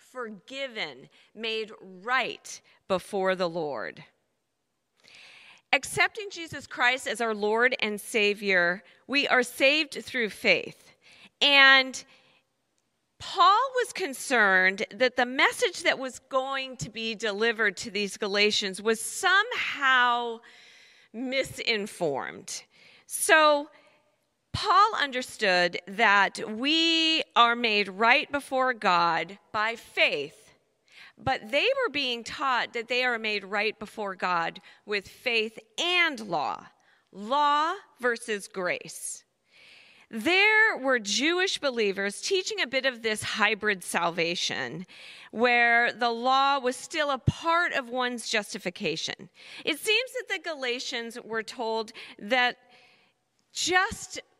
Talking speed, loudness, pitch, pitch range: 110 wpm, -25 LUFS, 245 Hz, 215-290 Hz